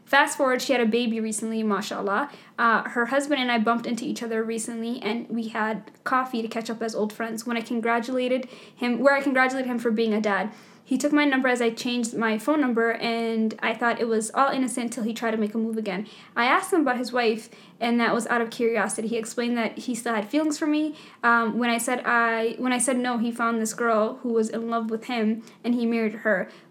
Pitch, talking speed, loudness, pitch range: 230 Hz, 245 wpm, -25 LUFS, 225-250 Hz